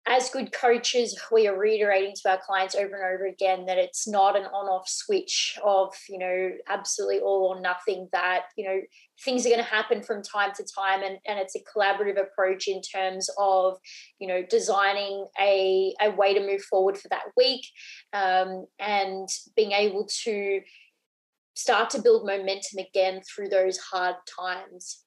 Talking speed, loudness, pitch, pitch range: 175 wpm, -26 LUFS, 195 Hz, 190-210 Hz